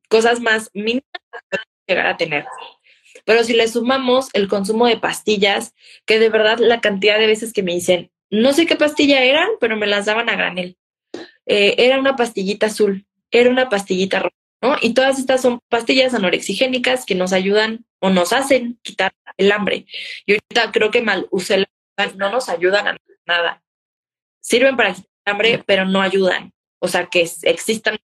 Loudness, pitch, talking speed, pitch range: -17 LUFS, 220 Hz, 180 wpm, 195-250 Hz